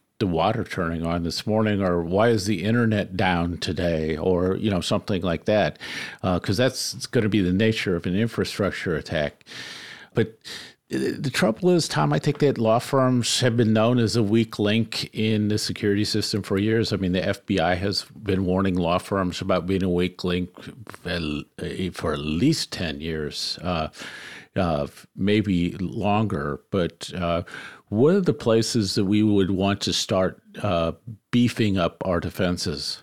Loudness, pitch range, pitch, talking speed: -23 LUFS, 90-110 Hz, 100 Hz, 170 wpm